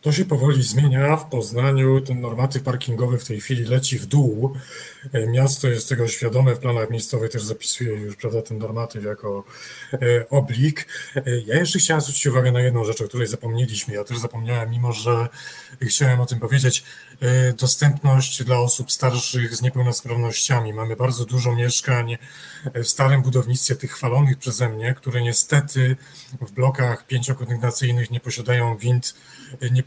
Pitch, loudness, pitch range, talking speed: 125 Hz, -20 LUFS, 120-135 Hz, 155 wpm